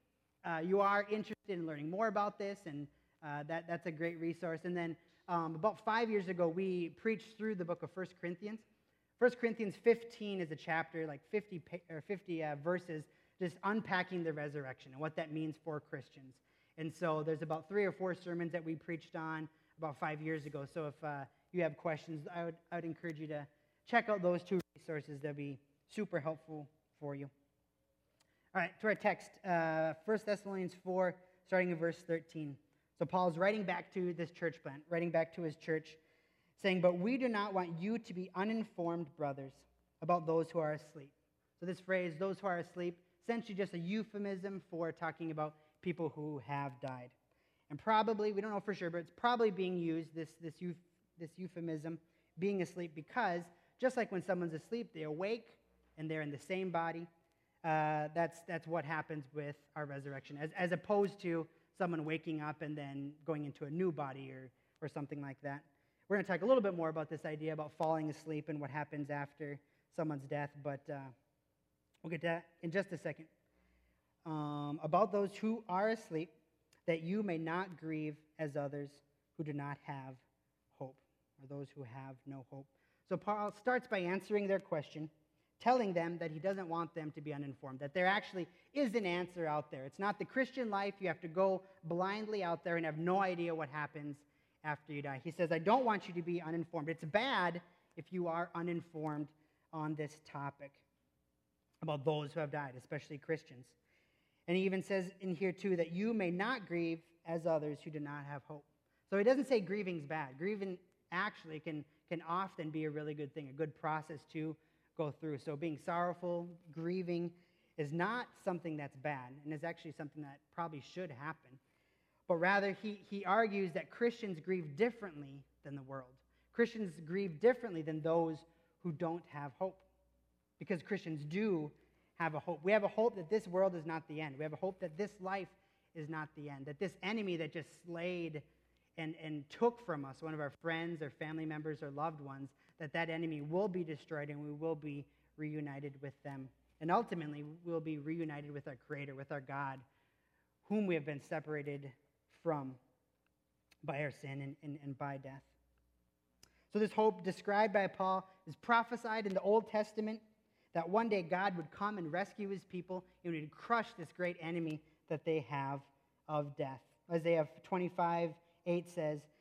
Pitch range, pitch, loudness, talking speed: 150-185 Hz, 165 Hz, -40 LUFS, 190 wpm